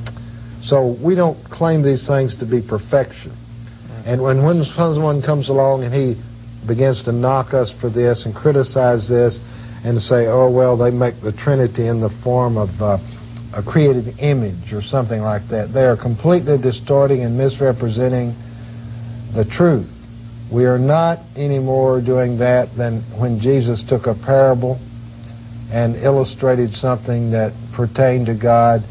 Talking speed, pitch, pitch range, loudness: 155 wpm, 120 Hz, 115-130 Hz, -16 LUFS